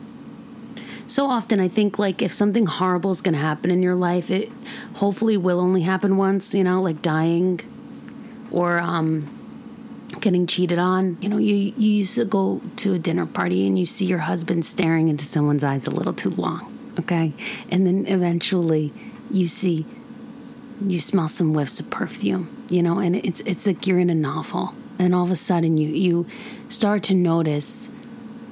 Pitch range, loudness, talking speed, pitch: 175-230 Hz, -21 LUFS, 180 wpm, 190 Hz